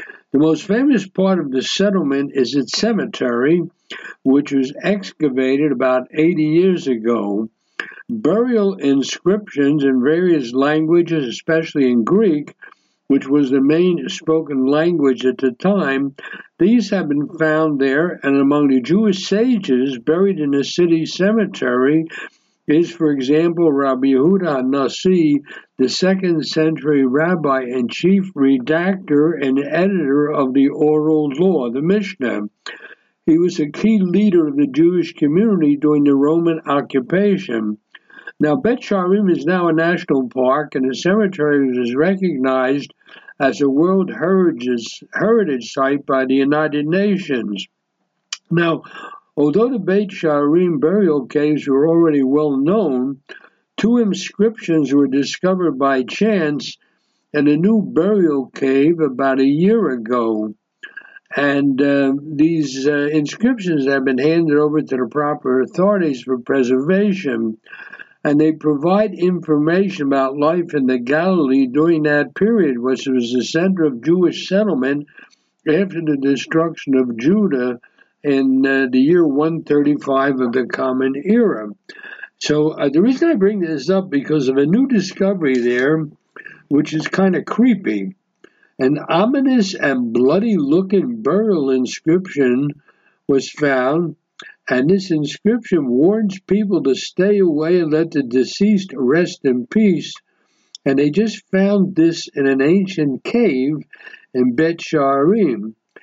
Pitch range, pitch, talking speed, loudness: 135-185 Hz, 150 Hz, 130 wpm, -17 LUFS